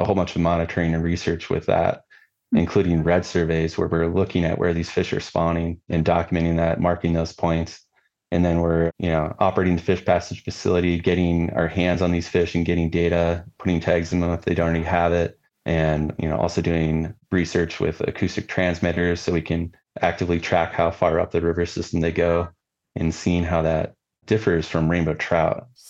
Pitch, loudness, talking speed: 85 Hz, -22 LUFS, 200 wpm